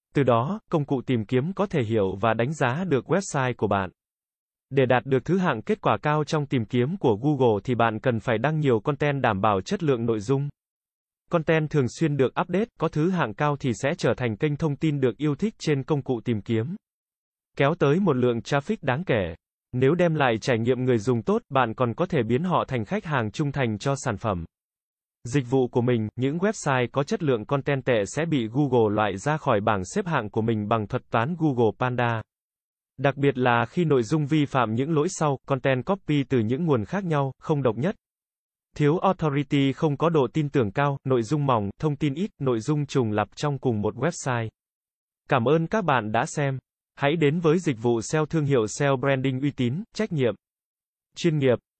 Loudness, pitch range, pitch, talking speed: -24 LUFS, 125-155 Hz, 140 Hz, 215 wpm